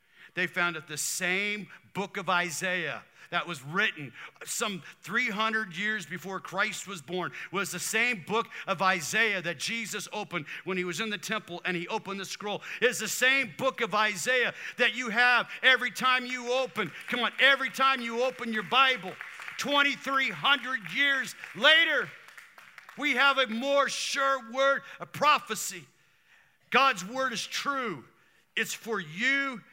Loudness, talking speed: -27 LUFS, 155 wpm